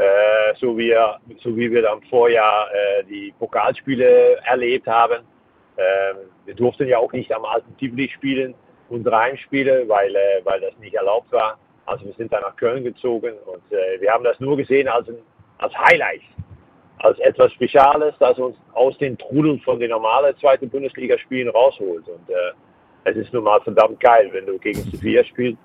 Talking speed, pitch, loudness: 180 wpm, 135 Hz, -18 LUFS